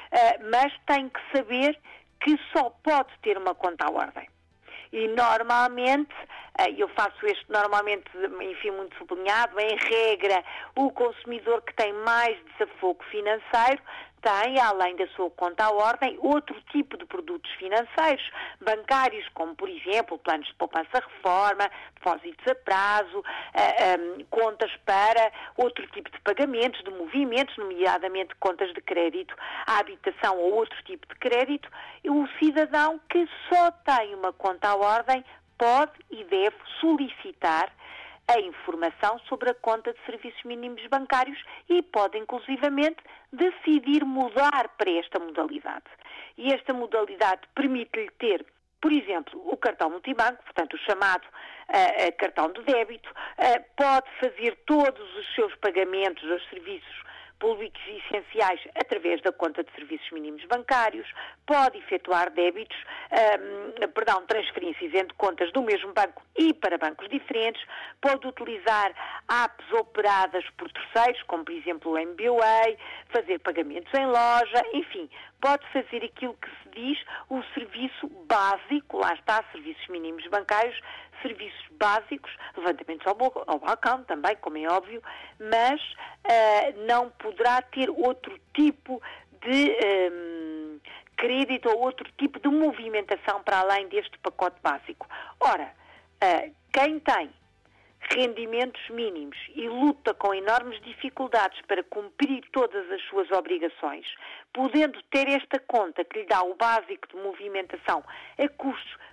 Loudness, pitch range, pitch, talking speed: -26 LUFS, 205-295 Hz, 245 Hz, 135 wpm